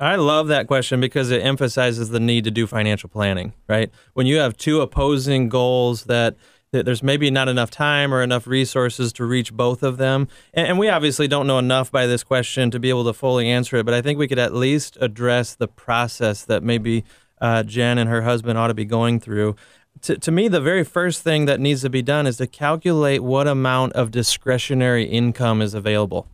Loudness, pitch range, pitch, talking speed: -19 LUFS, 115-140 Hz, 125 Hz, 220 wpm